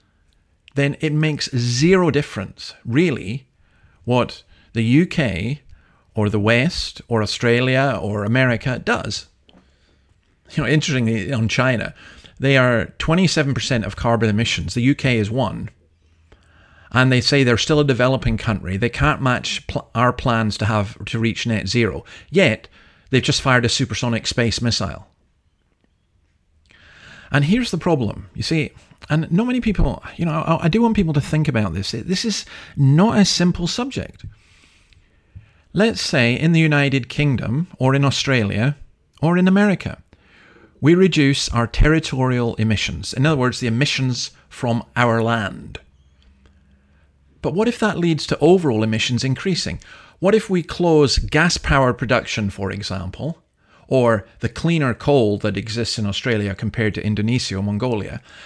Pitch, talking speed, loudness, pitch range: 120 Hz, 145 wpm, -19 LUFS, 100-145 Hz